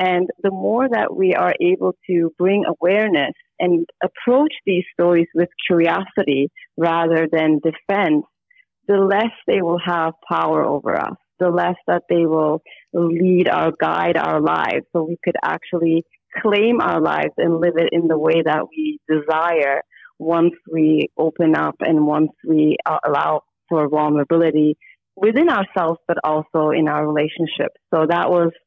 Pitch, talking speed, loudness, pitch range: 170 Hz, 155 wpm, -18 LUFS, 160-185 Hz